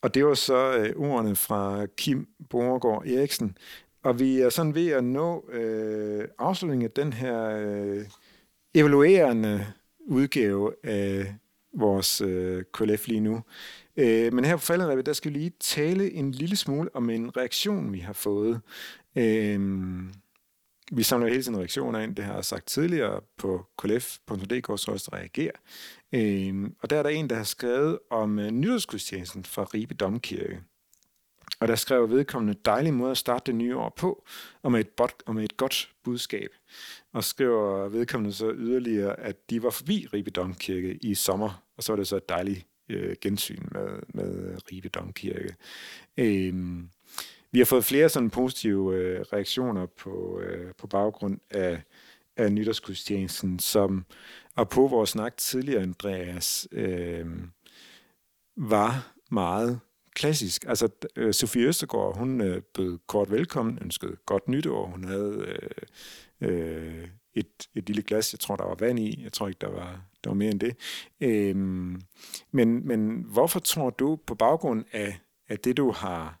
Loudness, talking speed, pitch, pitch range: -27 LUFS, 160 wpm, 110 Hz, 100-125 Hz